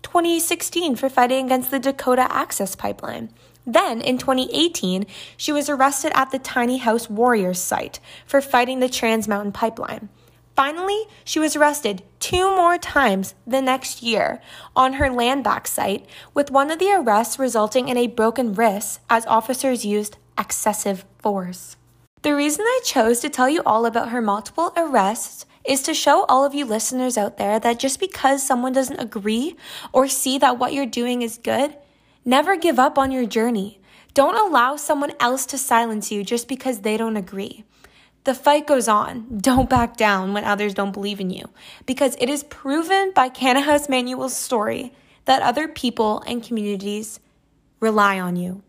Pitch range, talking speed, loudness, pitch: 220-275 Hz, 170 wpm, -20 LUFS, 255 Hz